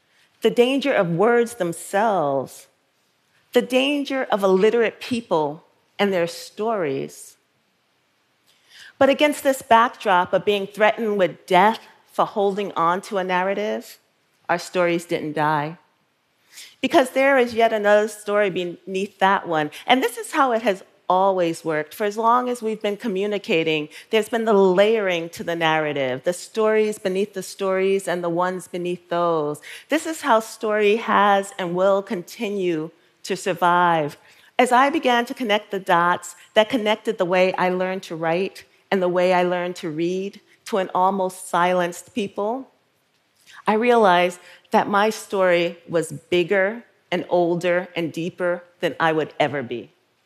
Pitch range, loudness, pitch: 175-215 Hz, -21 LUFS, 190 Hz